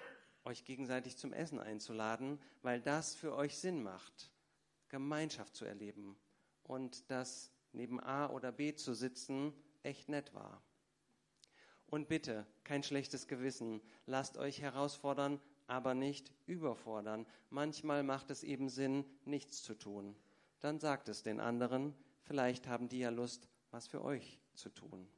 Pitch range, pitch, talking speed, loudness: 120-145 Hz, 135 Hz, 140 wpm, -43 LUFS